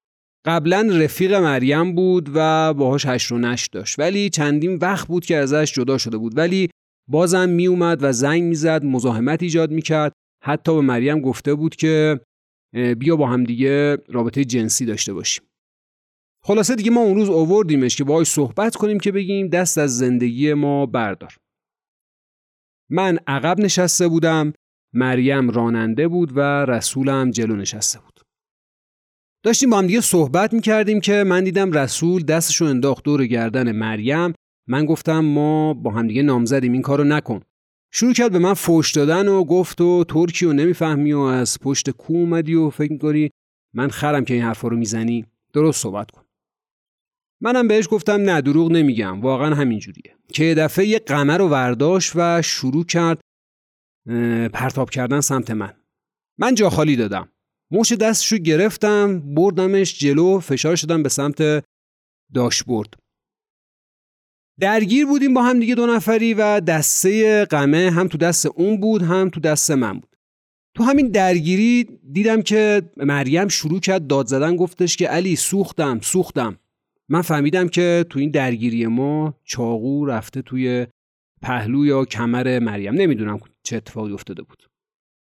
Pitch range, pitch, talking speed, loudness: 130-180 Hz, 150 Hz, 155 wpm, -18 LUFS